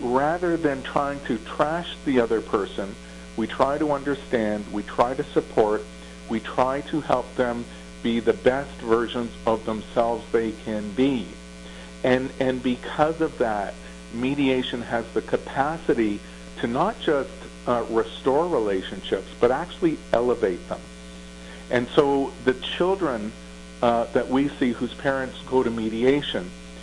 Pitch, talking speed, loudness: 115 Hz, 140 wpm, -25 LUFS